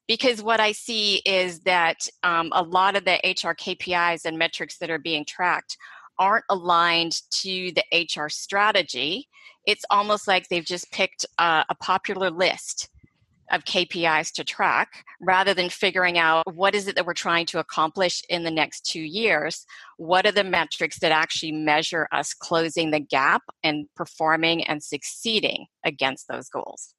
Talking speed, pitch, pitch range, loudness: 165 wpm, 175 Hz, 165-195 Hz, -23 LUFS